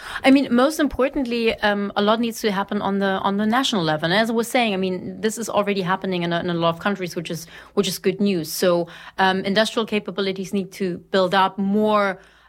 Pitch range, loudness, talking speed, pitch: 190-220 Hz, -21 LUFS, 235 wpm, 200 Hz